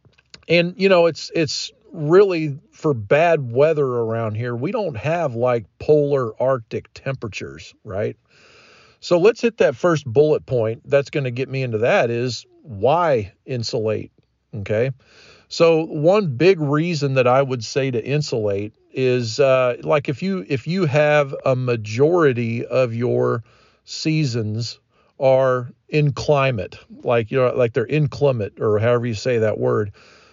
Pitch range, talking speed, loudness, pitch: 120-150 Hz, 145 wpm, -19 LUFS, 135 Hz